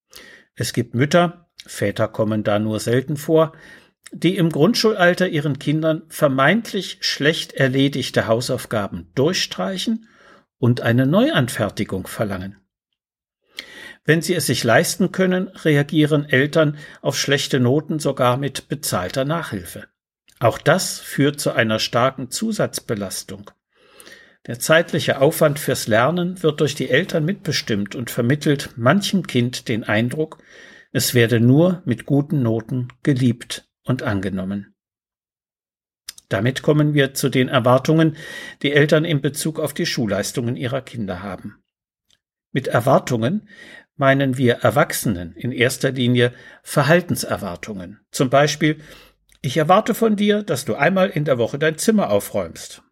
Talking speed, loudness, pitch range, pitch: 125 wpm, -19 LUFS, 120-165 Hz, 140 Hz